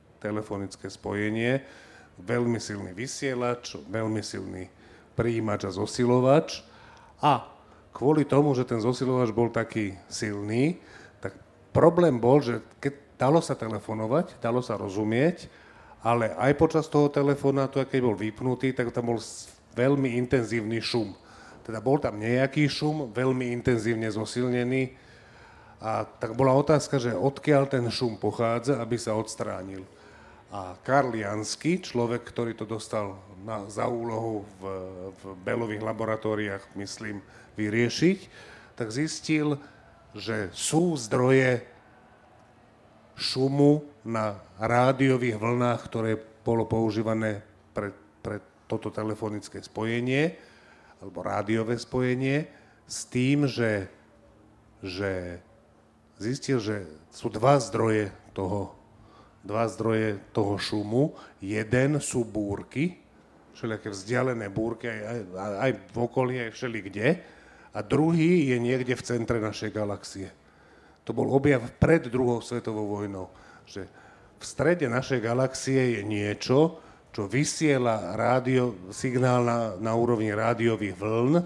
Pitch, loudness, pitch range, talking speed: 115 Hz, -27 LUFS, 105-130 Hz, 115 wpm